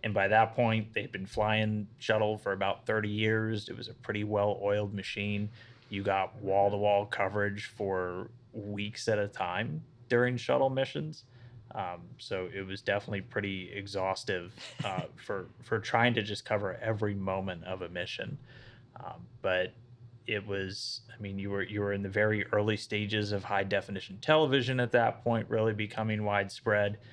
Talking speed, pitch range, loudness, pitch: 165 wpm, 100-115 Hz, -32 LUFS, 105 Hz